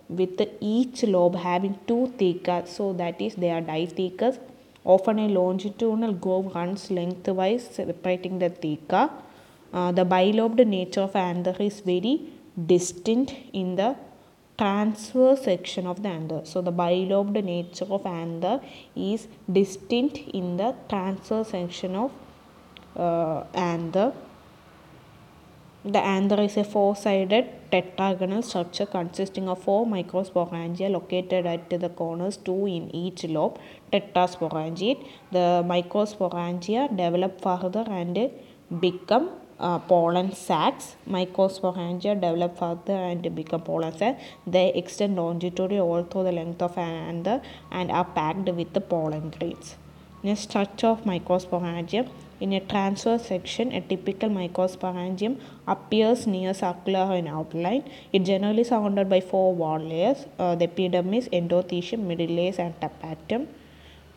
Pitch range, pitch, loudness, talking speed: 175-210 Hz, 185 Hz, -26 LUFS, 125 wpm